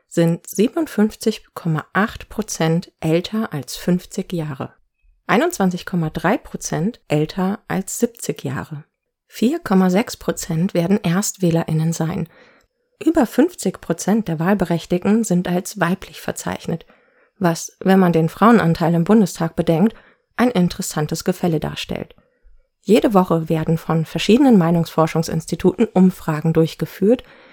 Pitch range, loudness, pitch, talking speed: 165-210 Hz, -19 LUFS, 180 Hz, 95 wpm